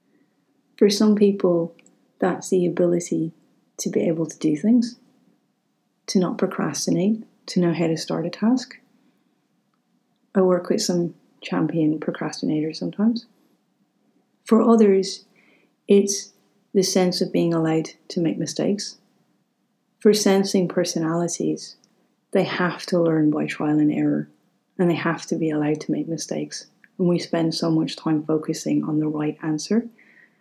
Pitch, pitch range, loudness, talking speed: 180 Hz, 160-205 Hz, -22 LUFS, 140 wpm